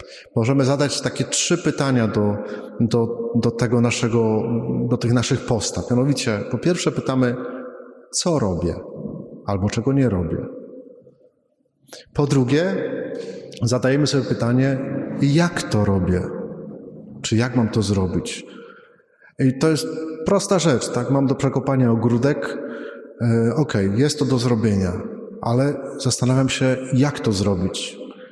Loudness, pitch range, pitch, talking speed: -20 LUFS, 115-140 Hz, 125 Hz, 115 wpm